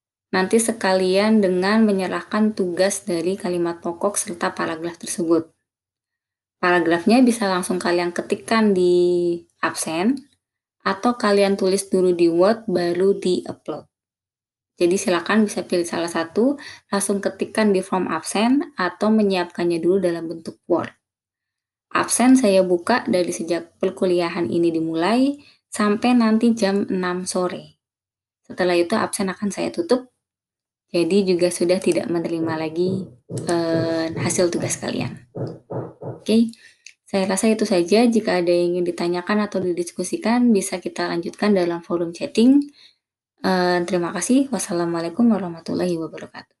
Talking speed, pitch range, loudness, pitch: 125 wpm, 175-210 Hz, -20 LUFS, 185 Hz